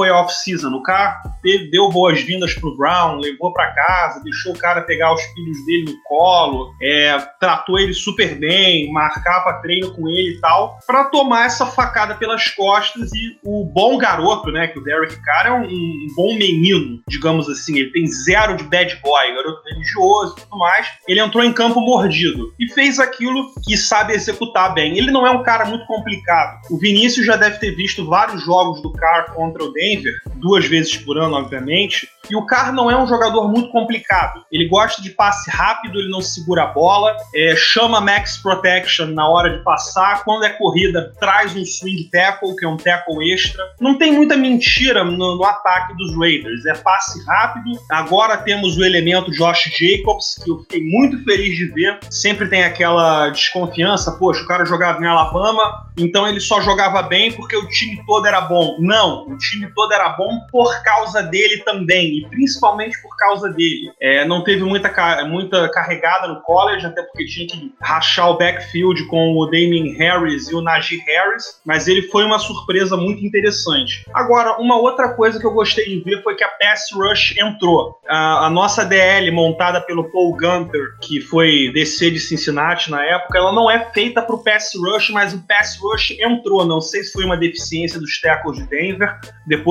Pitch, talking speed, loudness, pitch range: 185 Hz, 190 wpm, -15 LUFS, 165-215 Hz